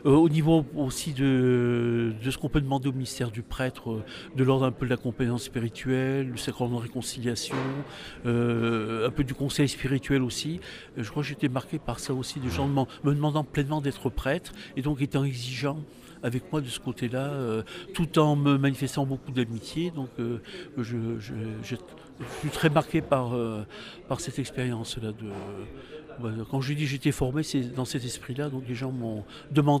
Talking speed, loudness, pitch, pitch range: 195 wpm, -29 LUFS, 130 Hz, 120-145 Hz